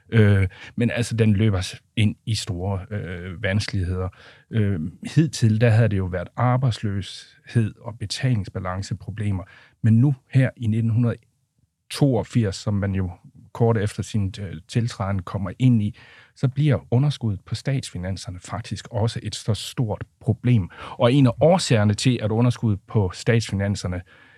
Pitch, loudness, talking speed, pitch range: 110 Hz, -23 LUFS, 135 wpm, 100-120 Hz